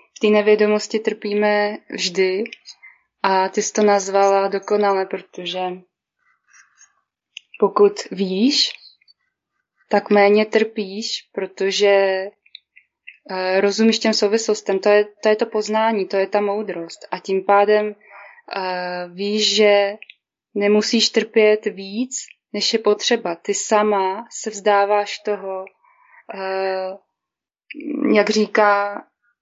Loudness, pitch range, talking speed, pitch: -19 LUFS, 195-215 Hz, 100 wpm, 205 Hz